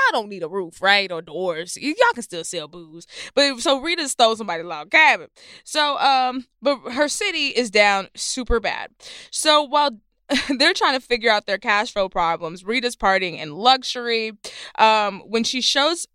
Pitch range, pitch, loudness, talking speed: 195-280 Hz, 235 Hz, -20 LUFS, 180 wpm